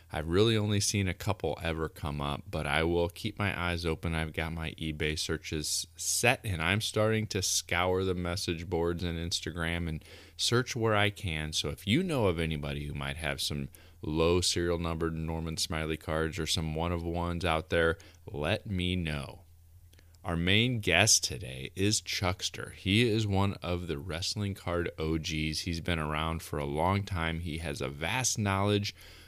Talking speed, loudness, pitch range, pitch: 180 wpm, -31 LUFS, 80-95 Hz, 85 Hz